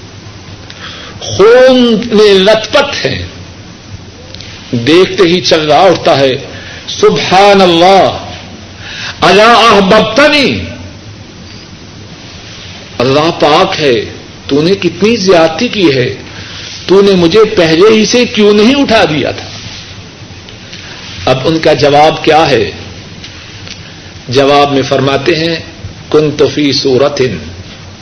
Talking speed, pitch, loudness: 90 wpm, 135 Hz, -7 LUFS